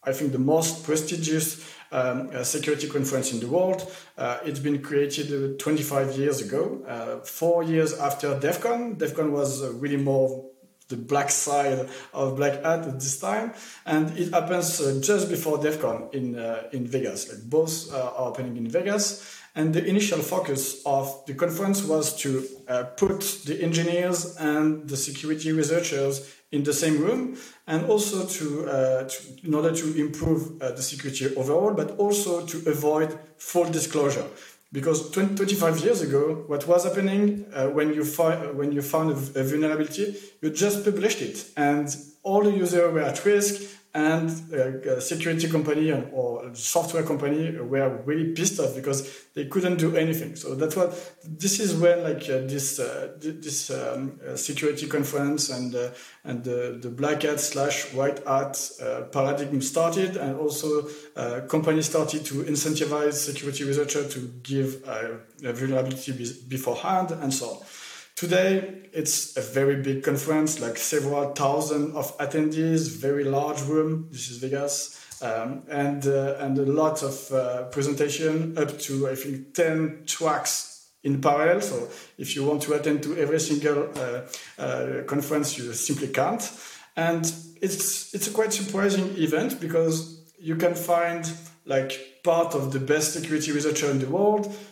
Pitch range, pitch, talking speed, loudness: 140-165 Hz, 150 Hz, 165 wpm, -26 LUFS